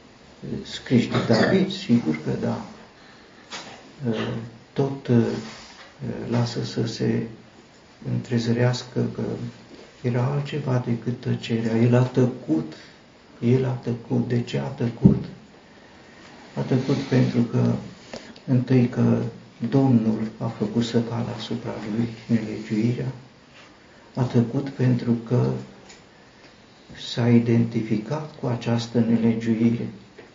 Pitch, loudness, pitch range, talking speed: 120 Hz, -24 LUFS, 115-125 Hz, 95 wpm